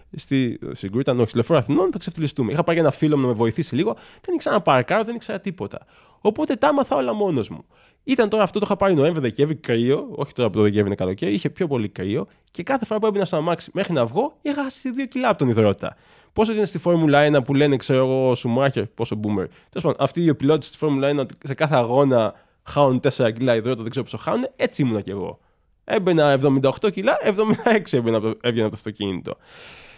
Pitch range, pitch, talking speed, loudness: 125-205 Hz, 145 Hz, 230 wpm, -21 LUFS